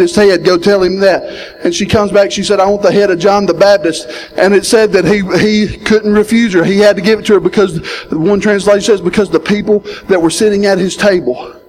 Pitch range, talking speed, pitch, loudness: 185-210 Hz, 255 wpm, 200 Hz, -10 LUFS